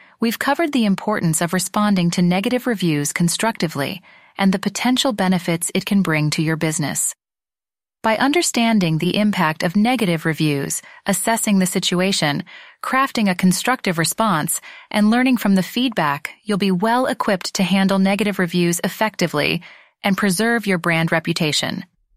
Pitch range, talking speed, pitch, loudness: 170-220 Hz, 145 wpm, 195 Hz, -19 LUFS